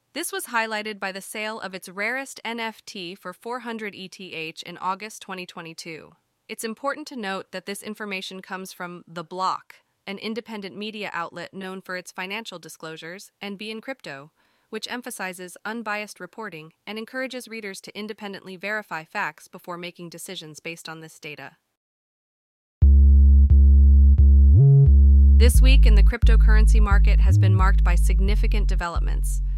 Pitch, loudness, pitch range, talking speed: 185 Hz, -21 LUFS, 140-215 Hz, 140 wpm